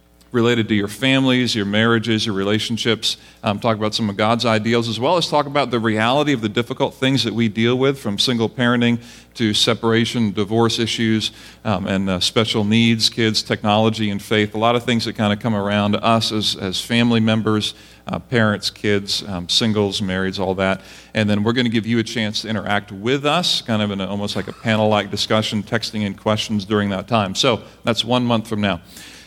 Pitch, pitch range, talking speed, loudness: 110 Hz, 105-115 Hz, 215 wpm, -19 LUFS